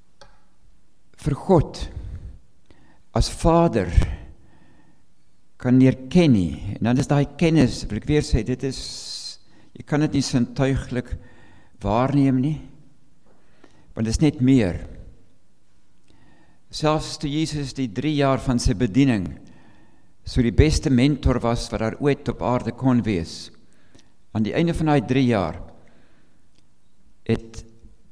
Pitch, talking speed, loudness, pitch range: 125 Hz, 125 wpm, -22 LUFS, 105-140 Hz